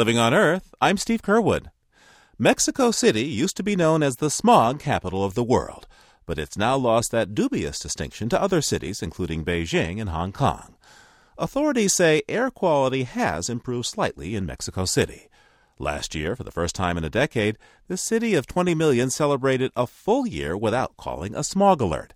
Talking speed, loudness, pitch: 180 wpm, -23 LUFS, 135 Hz